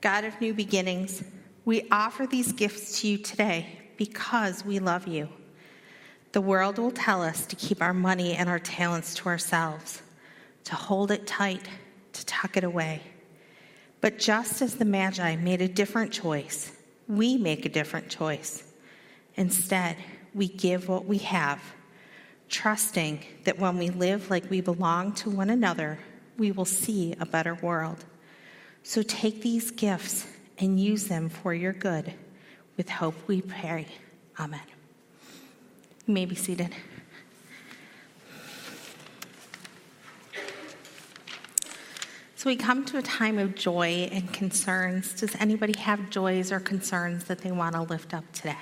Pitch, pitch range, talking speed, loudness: 190 Hz, 175-210 Hz, 145 wpm, -28 LUFS